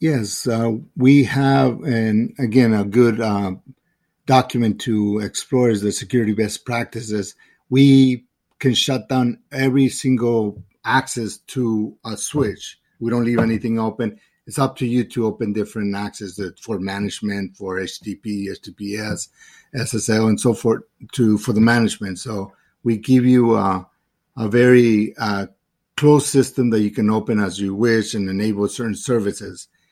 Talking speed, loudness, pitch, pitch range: 150 wpm, -19 LUFS, 115 Hz, 105-125 Hz